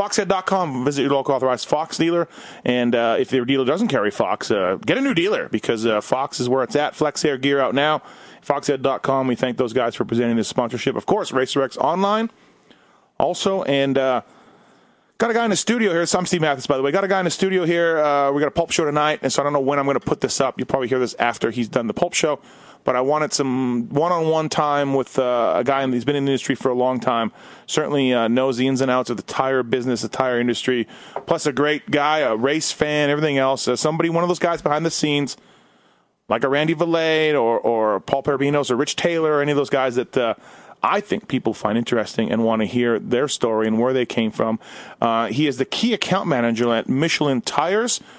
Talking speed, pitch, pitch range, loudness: 245 wpm, 135 Hz, 125-155 Hz, -20 LUFS